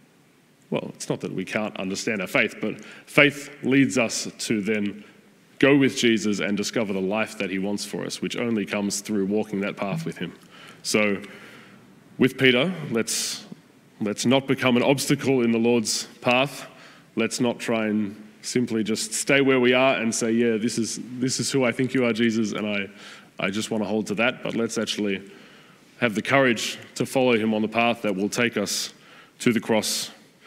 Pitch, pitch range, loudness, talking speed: 115 Hz, 105-125 Hz, -23 LUFS, 195 wpm